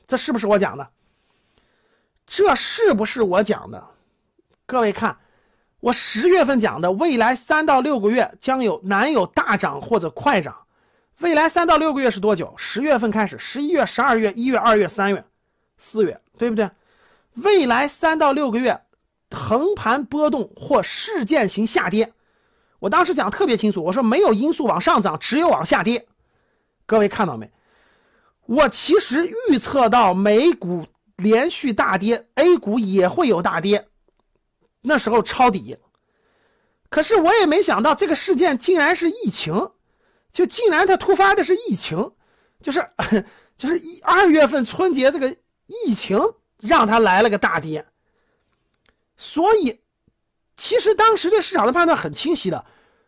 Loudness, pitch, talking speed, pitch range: -18 LUFS, 270 Hz, 230 characters per minute, 220-340 Hz